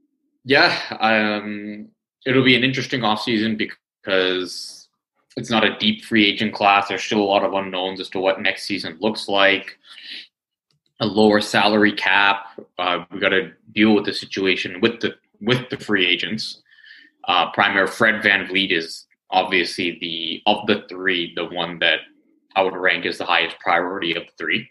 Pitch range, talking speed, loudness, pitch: 95-120 Hz, 170 wpm, -19 LUFS, 105 Hz